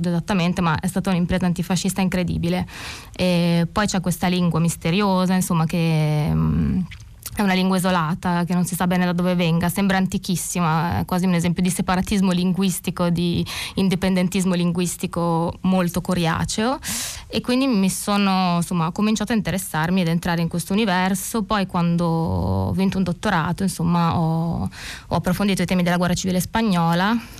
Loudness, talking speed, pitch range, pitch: -21 LUFS, 155 wpm, 170-190 Hz, 180 Hz